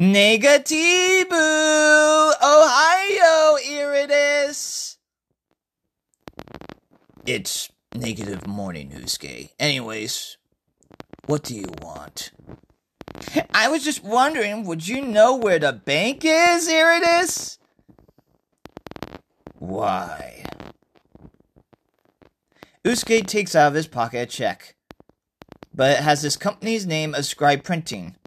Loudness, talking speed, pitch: -19 LUFS, 90 wpm, 225 Hz